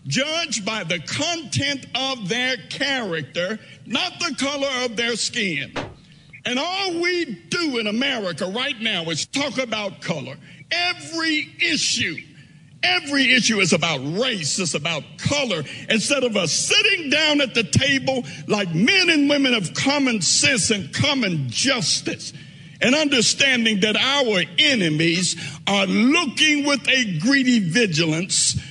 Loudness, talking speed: -19 LUFS, 135 wpm